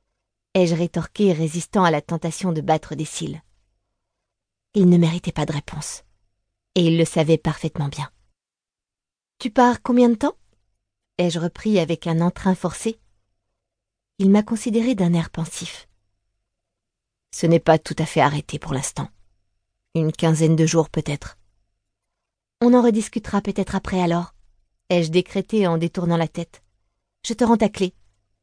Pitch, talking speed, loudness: 160 Hz, 155 wpm, -21 LUFS